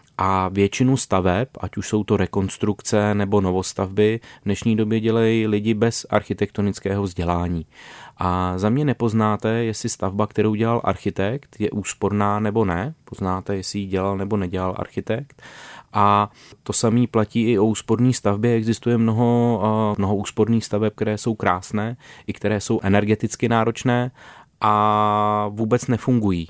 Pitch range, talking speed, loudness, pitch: 100-115 Hz, 140 wpm, -21 LUFS, 105 Hz